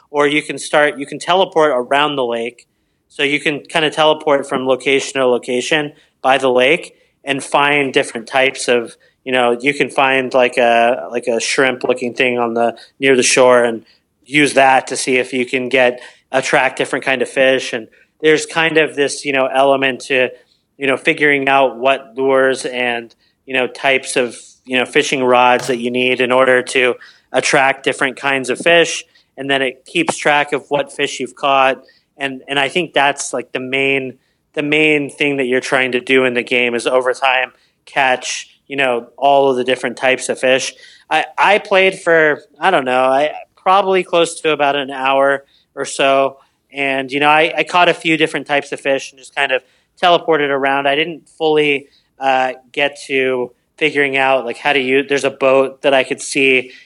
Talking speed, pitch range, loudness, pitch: 200 wpm, 130-145 Hz, -15 LUFS, 135 Hz